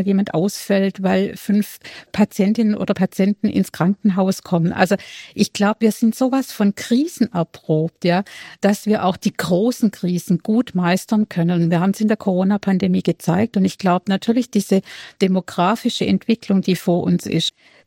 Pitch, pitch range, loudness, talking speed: 195 Hz, 180-210 Hz, -19 LUFS, 160 wpm